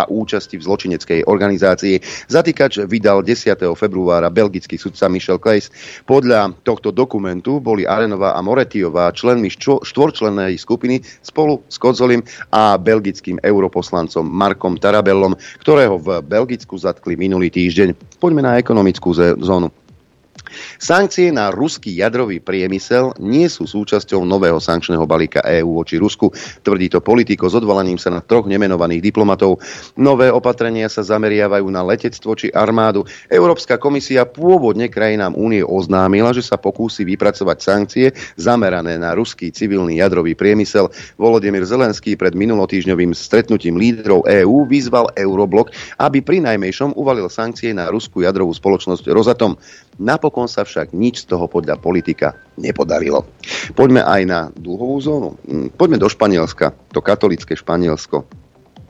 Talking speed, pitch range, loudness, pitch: 135 wpm, 95-120 Hz, -15 LUFS, 100 Hz